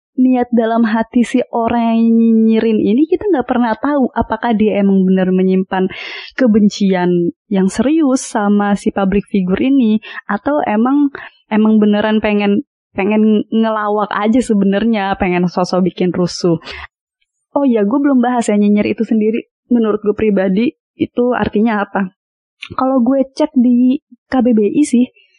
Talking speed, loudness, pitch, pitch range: 135 wpm, -14 LUFS, 225 Hz, 205-250 Hz